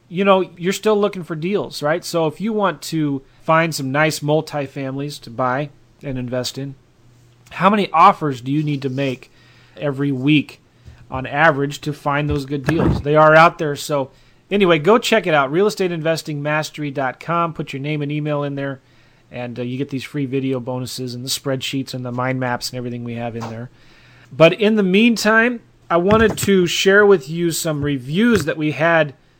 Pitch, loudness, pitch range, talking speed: 145 Hz, -18 LUFS, 130-170 Hz, 190 wpm